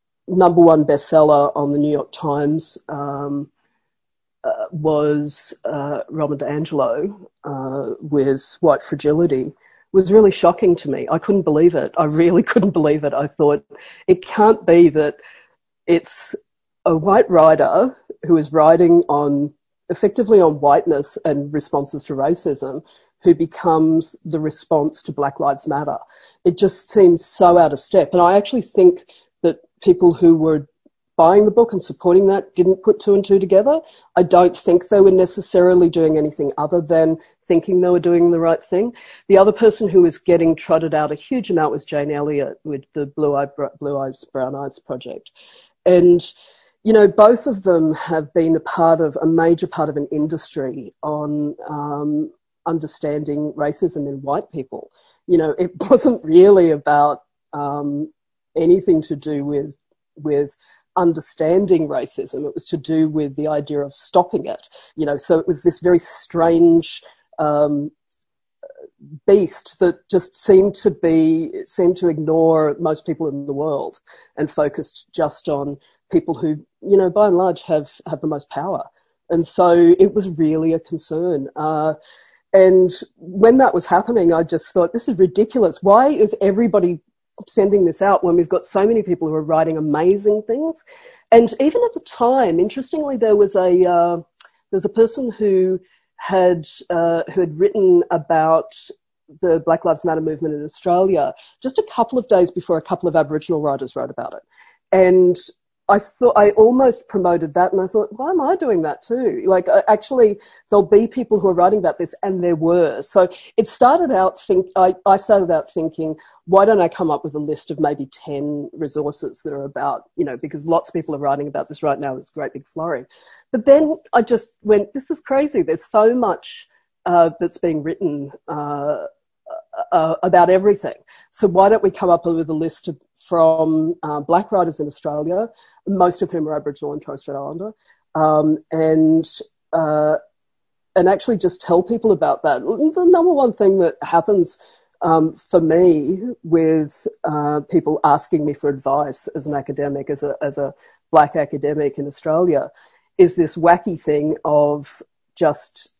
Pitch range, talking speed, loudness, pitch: 155-200 Hz, 175 wpm, -17 LUFS, 170 Hz